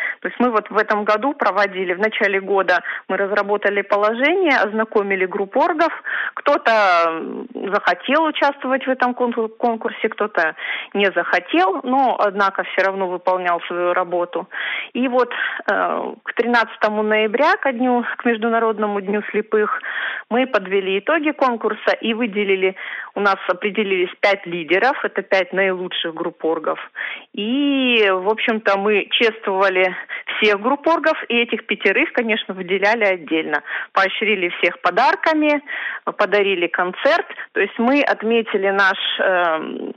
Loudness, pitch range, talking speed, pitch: -18 LUFS, 195-240 Hz, 125 wpm, 210 Hz